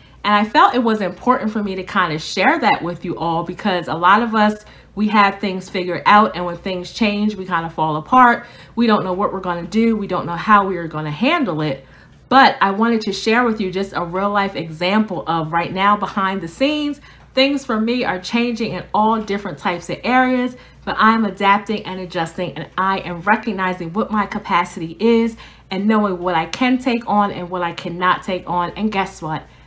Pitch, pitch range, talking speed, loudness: 195 Hz, 180-220 Hz, 225 wpm, -18 LUFS